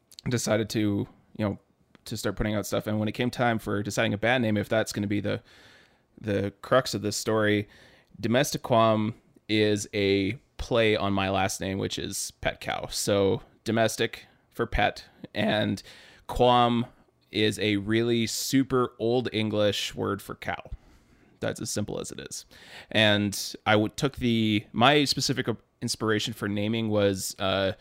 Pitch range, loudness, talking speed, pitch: 105-115 Hz, -27 LUFS, 165 wpm, 110 Hz